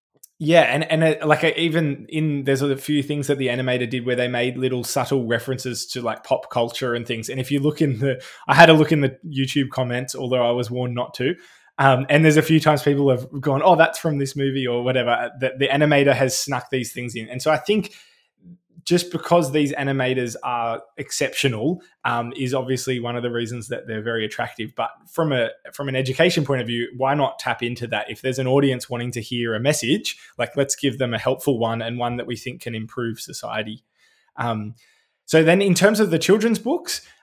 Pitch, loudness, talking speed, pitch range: 130 Hz, -21 LUFS, 220 wpm, 120-150 Hz